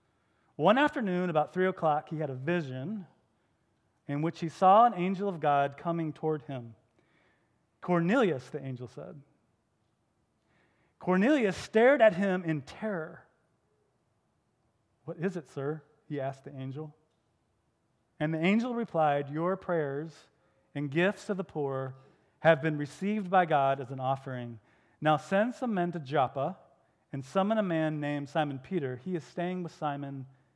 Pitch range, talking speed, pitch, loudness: 135-180 Hz, 145 wpm, 155 Hz, -30 LUFS